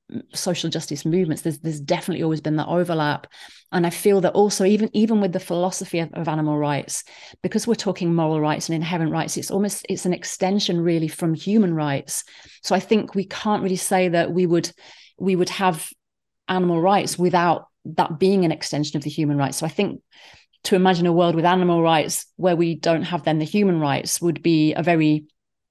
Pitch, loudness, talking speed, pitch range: 175 Hz, -21 LUFS, 205 wpm, 160-185 Hz